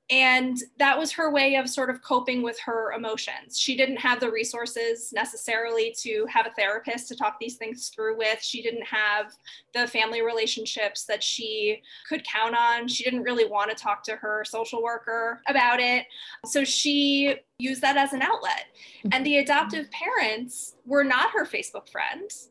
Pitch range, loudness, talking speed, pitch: 225-275 Hz, -25 LUFS, 180 wpm, 240 Hz